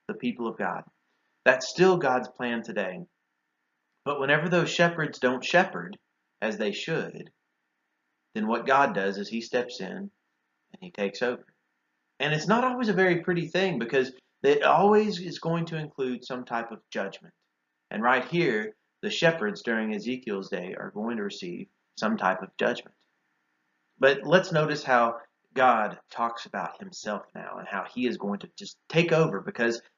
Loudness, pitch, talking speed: -27 LUFS, 125 Hz, 170 wpm